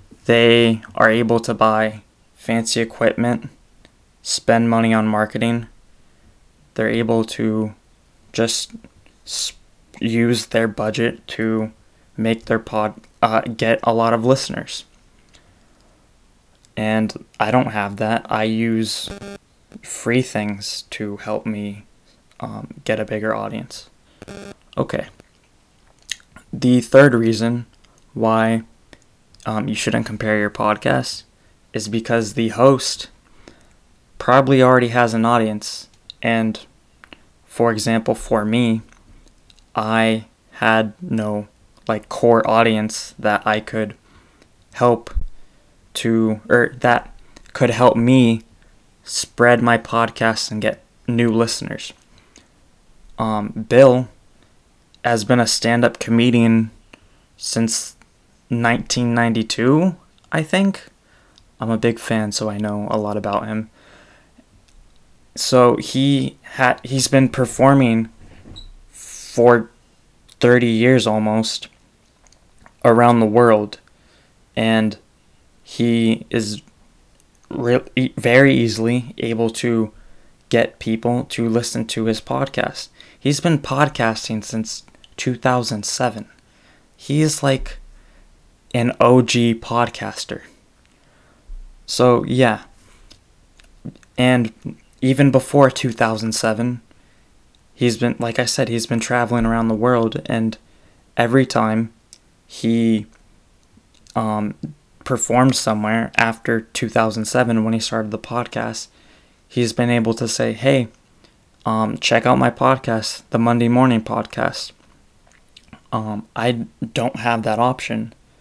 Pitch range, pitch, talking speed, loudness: 110-120 Hz, 115 Hz, 105 wpm, -18 LUFS